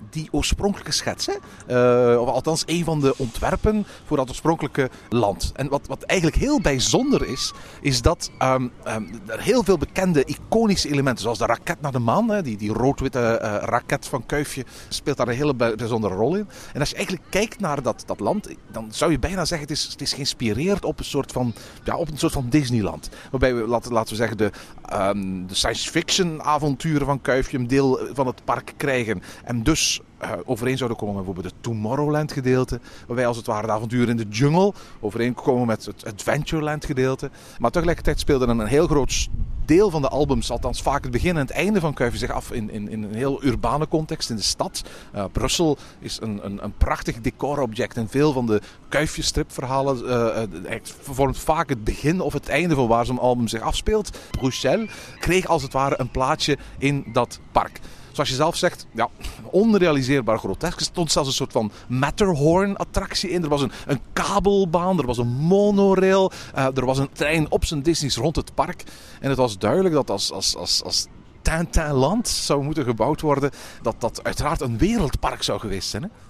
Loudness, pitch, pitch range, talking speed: -22 LUFS, 135 Hz, 115-155 Hz, 200 wpm